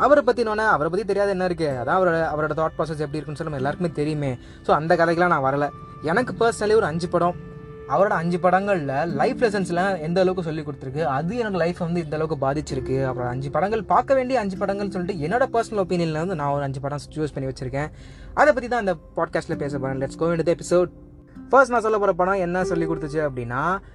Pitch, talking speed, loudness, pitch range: 170 Hz, 210 wpm, -23 LUFS, 150-195 Hz